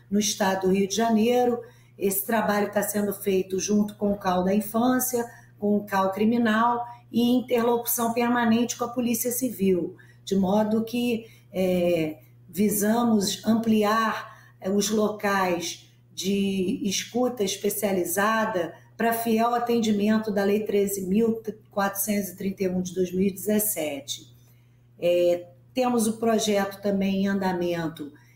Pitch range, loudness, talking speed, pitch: 185-225 Hz, -25 LUFS, 115 wpm, 205 Hz